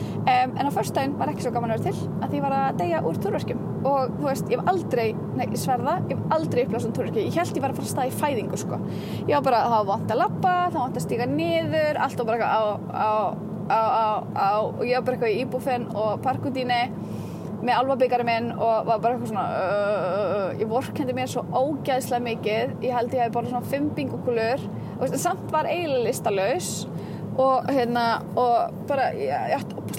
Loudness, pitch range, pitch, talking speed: -25 LUFS, 225-260 Hz, 245 Hz, 180 wpm